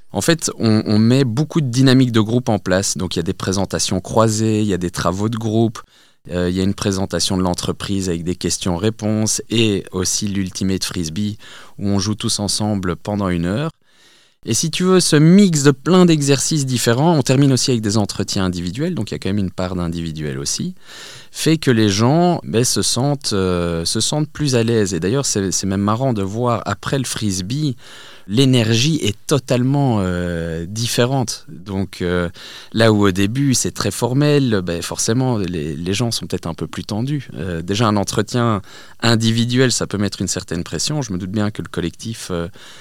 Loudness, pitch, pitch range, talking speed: -18 LUFS, 105 Hz, 95-125 Hz, 200 wpm